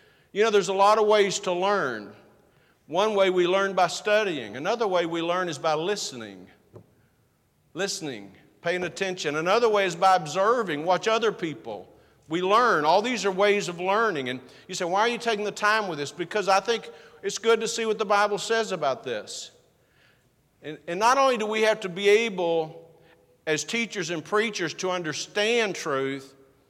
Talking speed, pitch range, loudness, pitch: 185 wpm, 160-210 Hz, -24 LUFS, 190 Hz